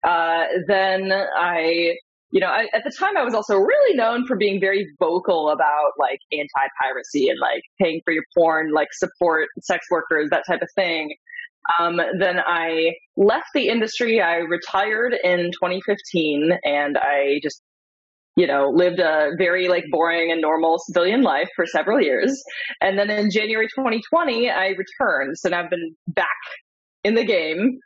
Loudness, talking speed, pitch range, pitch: -20 LUFS, 165 wpm, 165-210 Hz, 180 Hz